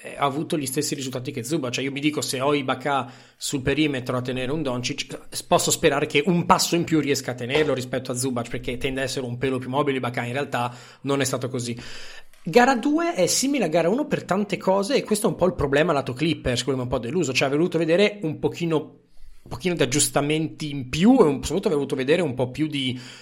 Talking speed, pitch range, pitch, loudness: 245 wpm, 130-165 Hz, 145 Hz, -23 LUFS